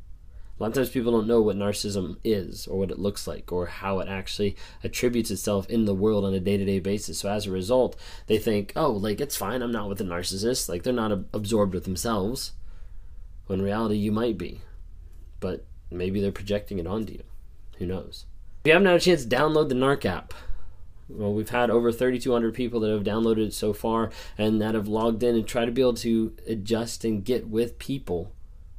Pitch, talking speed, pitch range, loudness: 105 Hz, 215 wpm, 95-115 Hz, -26 LUFS